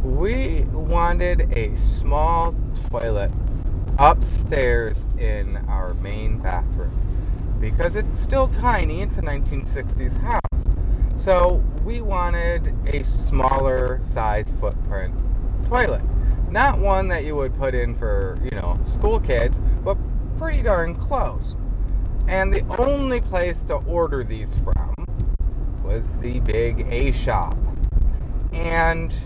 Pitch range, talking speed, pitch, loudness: 90-120 Hz, 115 wpm, 100 Hz, -23 LUFS